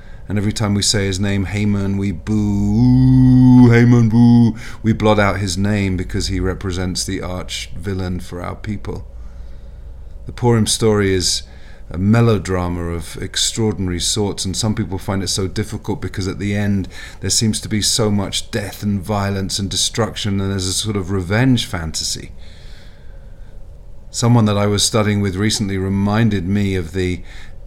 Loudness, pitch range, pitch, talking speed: -17 LUFS, 95-105 Hz, 100 Hz, 165 wpm